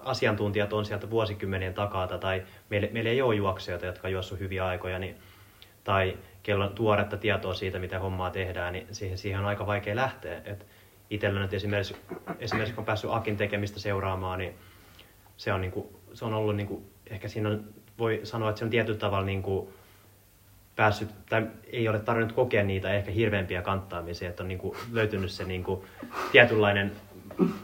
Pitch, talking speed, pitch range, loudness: 100 Hz, 180 wpm, 95-105 Hz, -29 LUFS